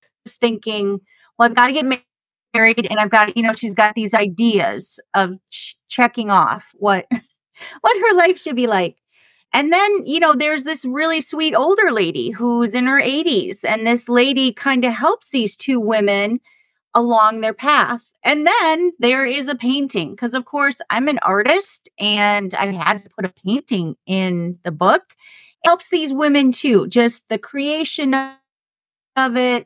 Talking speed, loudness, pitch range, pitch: 175 wpm, -17 LUFS, 215-295 Hz, 245 Hz